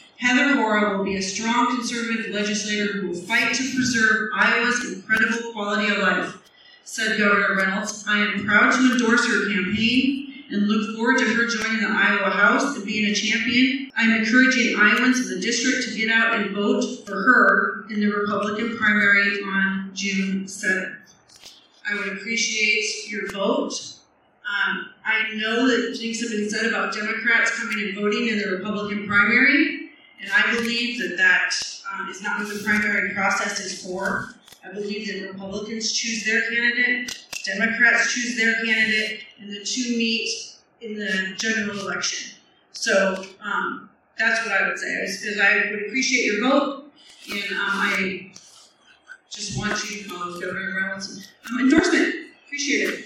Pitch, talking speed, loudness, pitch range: 215 Hz, 160 wpm, -21 LUFS, 205-240 Hz